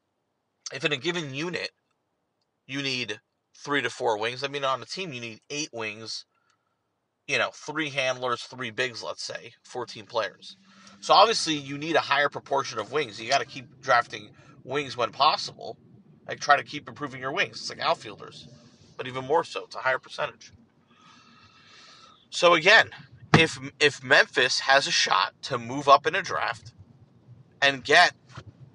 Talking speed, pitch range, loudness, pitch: 170 wpm, 125-155 Hz, -25 LUFS, 140 Hz